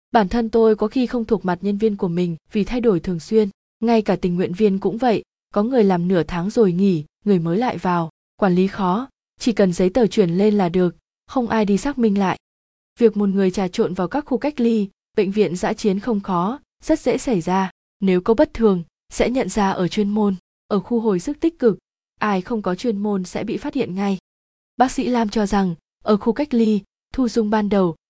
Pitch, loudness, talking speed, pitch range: 205 Hz, -20 LUFS, 235 wpm, 185-230 Hz